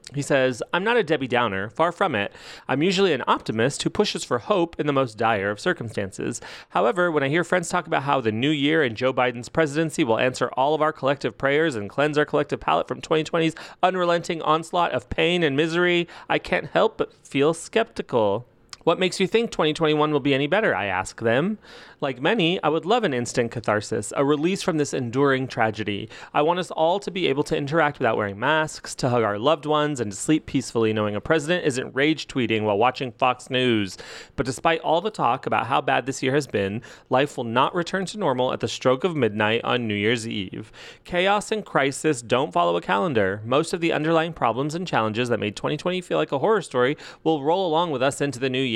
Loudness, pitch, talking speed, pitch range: -23 LUFS, 145 Hz, 220 wpm, 120-165 Hz